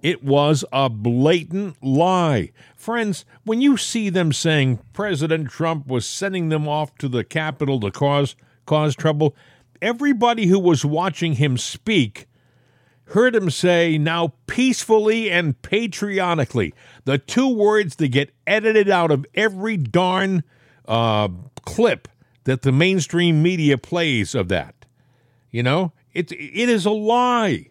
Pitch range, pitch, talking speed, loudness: 130-190 Hz, 155 Hz, 135 wpm, -20 LUFS